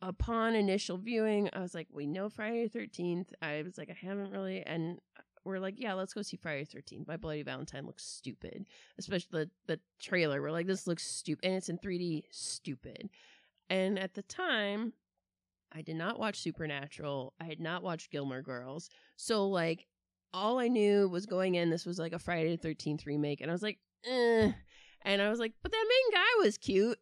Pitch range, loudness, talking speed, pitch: 160-210 Hz, -35 LUFS, 205 wpm, 185 Hz